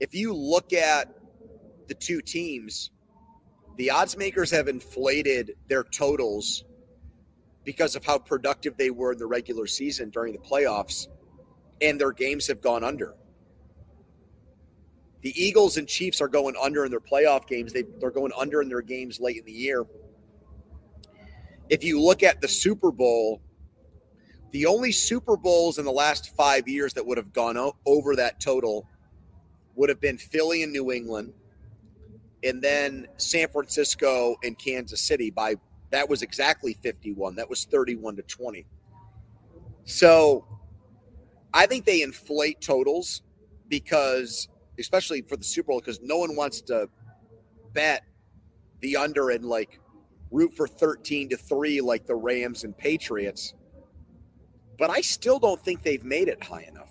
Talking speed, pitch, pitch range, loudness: 150 wpm, 130 Hz, 105-150 Hz, -25 LUFS